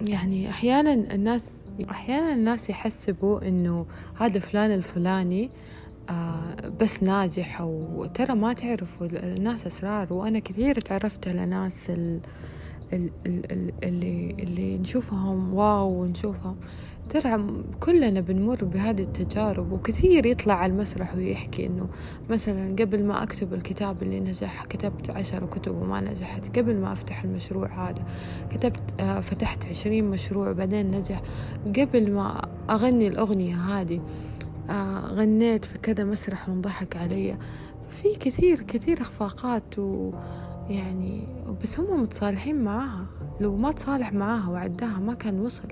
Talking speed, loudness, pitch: 120 wpm, -27 LUFS, 190 Hz